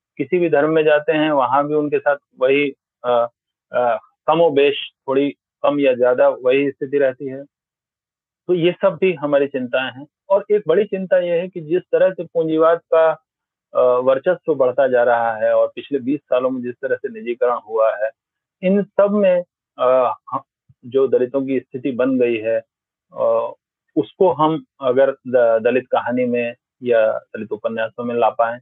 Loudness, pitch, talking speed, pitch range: -18 LUFS, 140 Hz, 170 wpm, 125-165 Hz